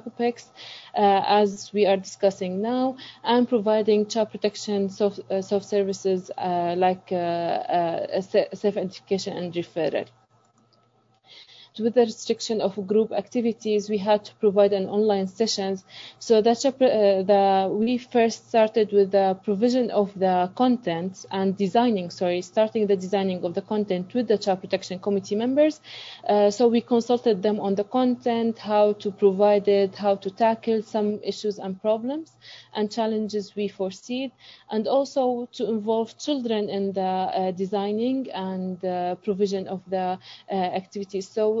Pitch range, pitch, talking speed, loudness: 190-225 Hz, 205 Hz, 145 wpm, -24 LUFS